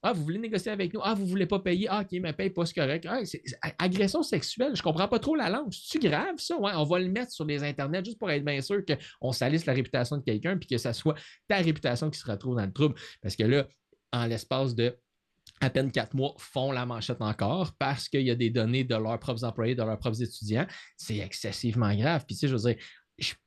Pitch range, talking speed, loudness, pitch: 120-180 Hz, 260 wpm, -30 LUFS, 140 Hz